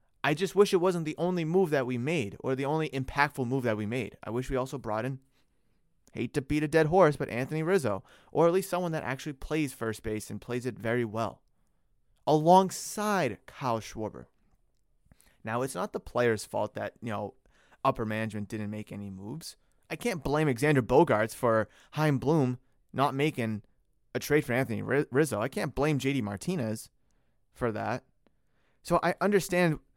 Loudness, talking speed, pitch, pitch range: -29 LUFS, 180 wpm, 135 Hz, 115-155 Hz